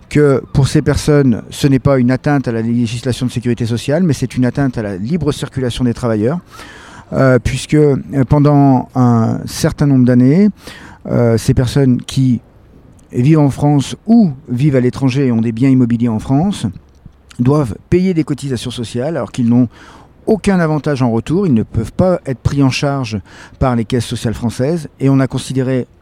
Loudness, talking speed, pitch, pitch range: -14 LUFS, 180 wpm, 130 Hz, 120-145 Hz